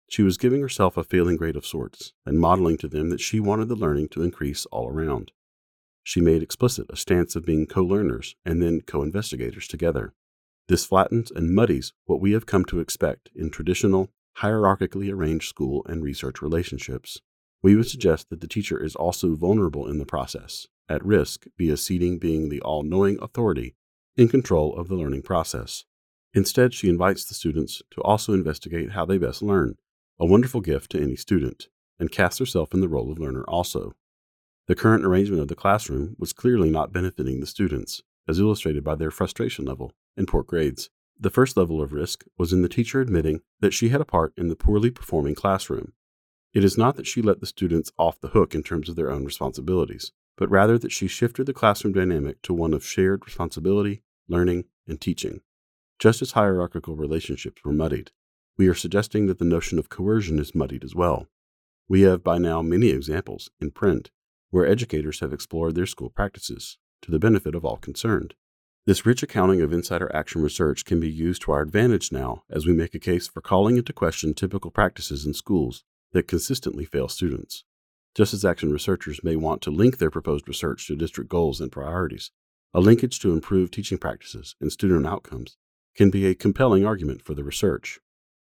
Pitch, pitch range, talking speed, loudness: 90 Hz, 75-100 Hz, 190 wpm, -24 LUFS